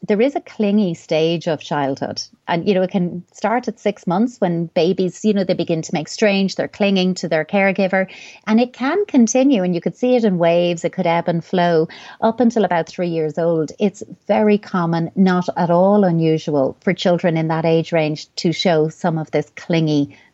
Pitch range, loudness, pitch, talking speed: 165-205 Hz, -18 LUFS, 180 Hz, 210 wpm